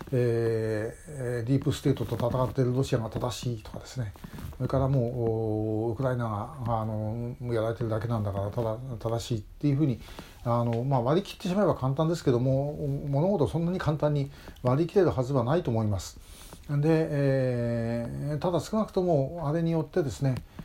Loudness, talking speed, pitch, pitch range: -29 LUFS, 370 characters per minute, 125 Hz, 115-145 Hz